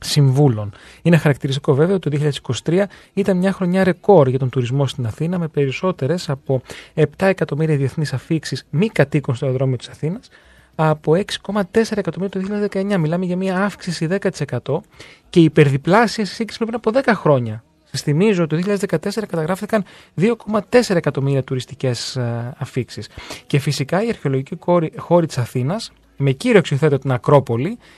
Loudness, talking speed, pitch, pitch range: -19 LUFS, 150 wpm, 155 Hz, 135-195 Hz